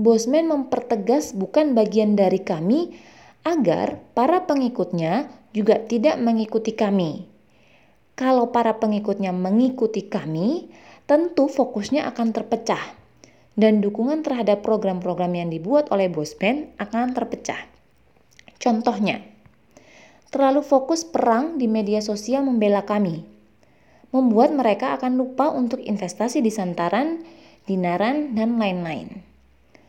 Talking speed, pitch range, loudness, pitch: 105 wpm, 200-260 Hz, -22 LUFS, 225 Hz